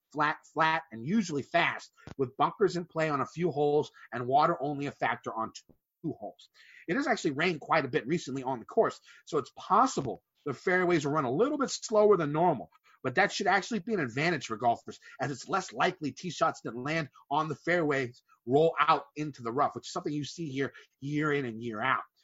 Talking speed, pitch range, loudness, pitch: 220 wpm, 135-175 Hz, -30 LUFS, 150 Hz